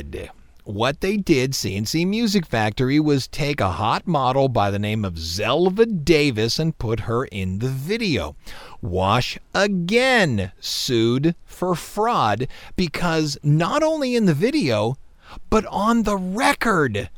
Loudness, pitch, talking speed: -21 LUFS, 150 Hz, 135 wpm